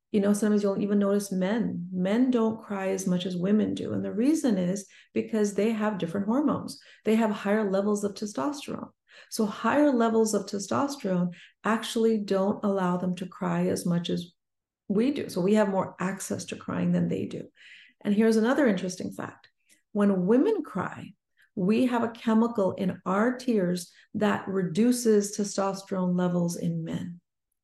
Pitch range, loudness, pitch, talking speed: 185-225 Hz, -27 LUFS, 205 Hz, 165 wpm